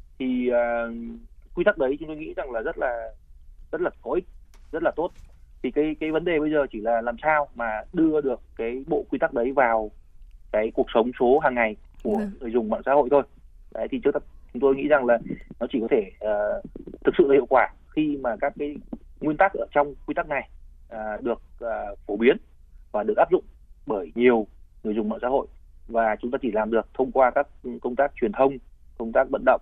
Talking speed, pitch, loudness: 230 wpm, 120 Hz, -25 LUFS